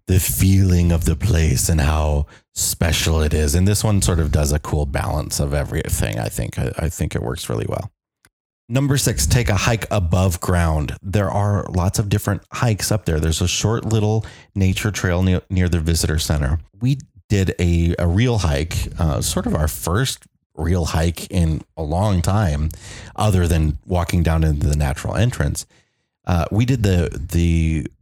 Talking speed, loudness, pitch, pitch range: 180 wpm, -19 LUFS, 90 Hz, 80-105 Hz